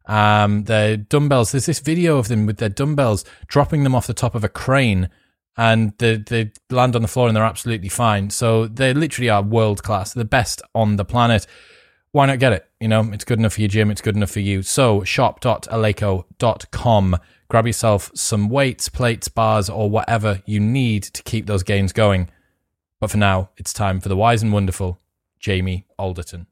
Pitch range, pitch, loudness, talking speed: 100-120 Hz, 110 Hz, -18 LUFS, 195 wpm